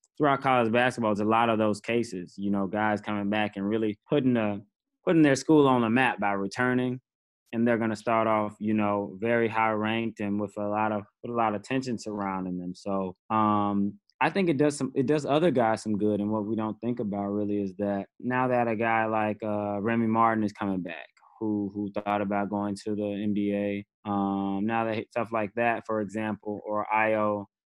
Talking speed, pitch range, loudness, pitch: 215 wpm, 100-115 Hz, -27 LUFS, 105 Hz